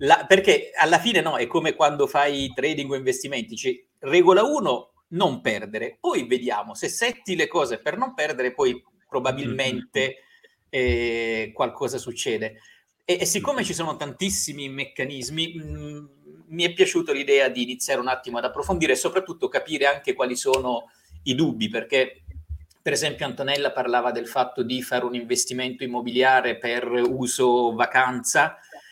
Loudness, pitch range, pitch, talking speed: -23 LUFS, 125-190 Hz, 135 Hz, 150 wpm